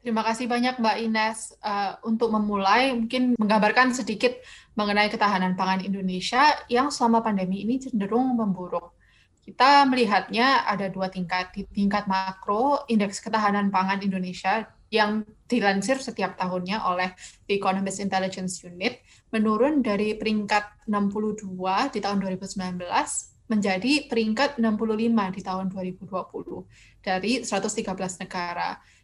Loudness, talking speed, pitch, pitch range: -25 LUFS, 120 wpm, 210 Hz, 190-230 Hz